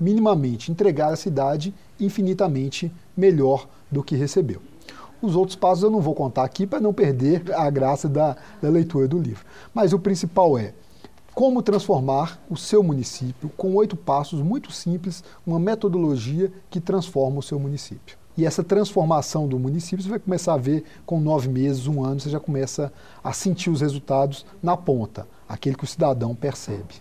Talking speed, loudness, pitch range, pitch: 170 wpm, -23 LUFS, 135-190 Hz, 155 Hz